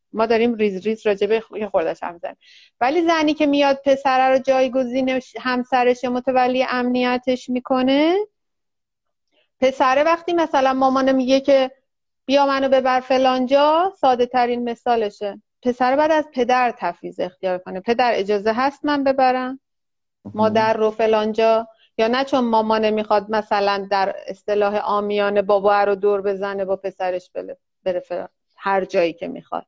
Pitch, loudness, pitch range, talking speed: 245 Hz, -19 LUFS, 210-265 Hz, 140 wpm